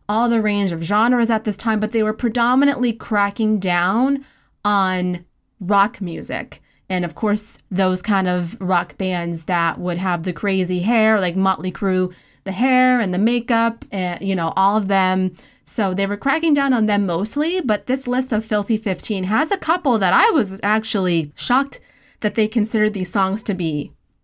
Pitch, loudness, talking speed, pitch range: 205 Hz, -19 LUFS, 185 wpm, 185-230 Hz